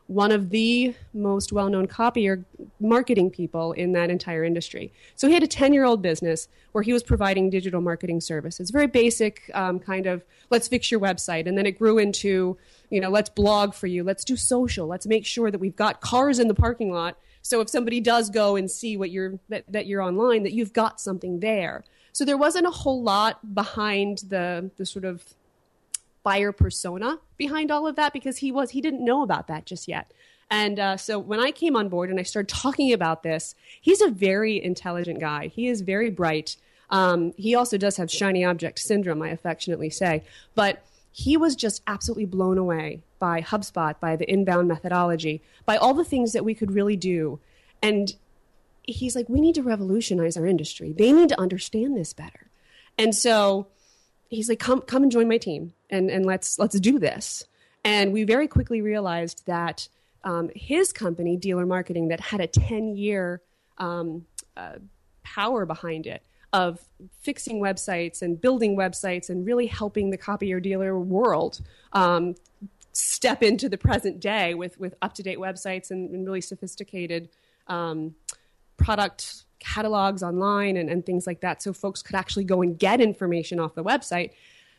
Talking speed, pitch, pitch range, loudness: 185 wpm, 195 Hz, 180-225 Hz, -24 LUFS